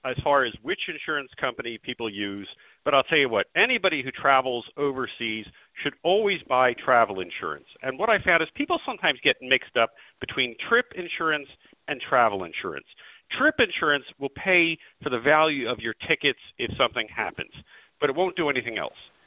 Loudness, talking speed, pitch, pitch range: -24 LUFS, 175 wpm, 140 Hz, 125-165 Hz